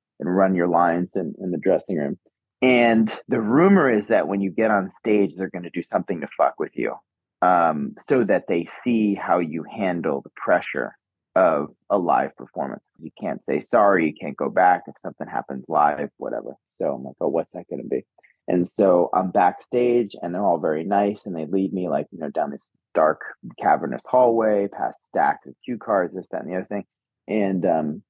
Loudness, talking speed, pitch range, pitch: -22 LUFS, 210 wpm, 85-105 Hz, 95 Hz